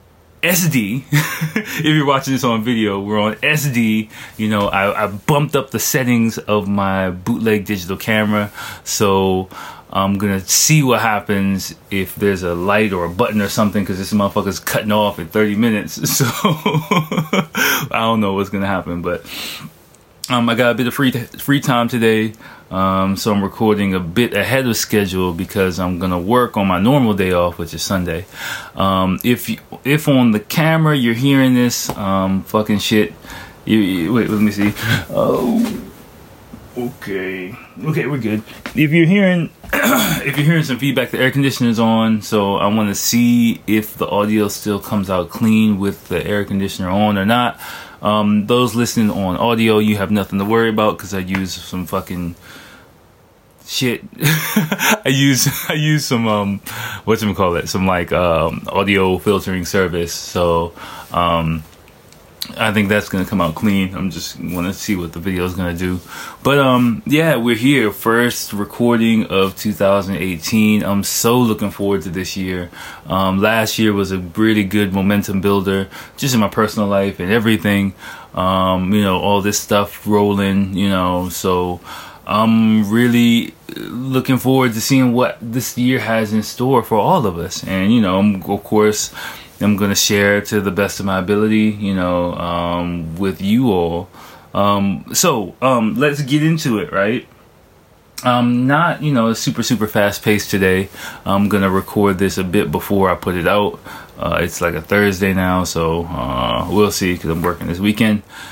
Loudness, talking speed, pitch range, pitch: -16 LUFS, 175 wpm, 95-120 Hz, 105 Hz